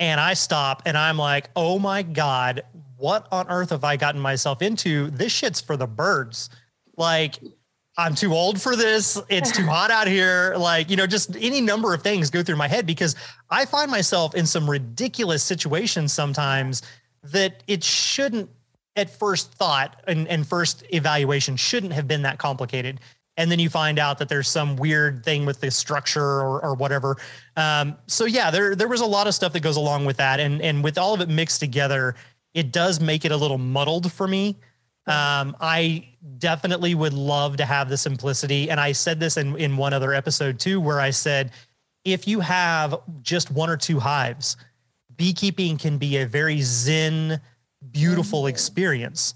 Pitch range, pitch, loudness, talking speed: 140-180 Hz, 155 Hz, -22 LUFS, 190 wpm